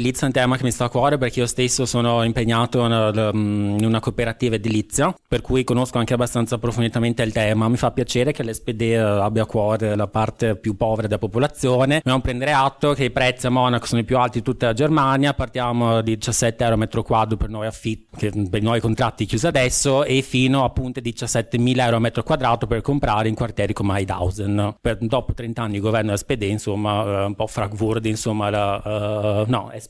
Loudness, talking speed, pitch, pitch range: -20 LUFS, 200 wpm, 115 Hz, 110-125 Hz